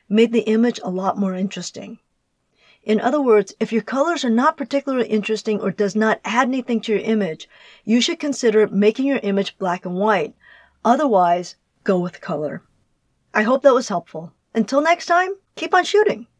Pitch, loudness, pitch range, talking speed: 220 Hz, -19 LUFS, 200-260 Hz, 180 wpm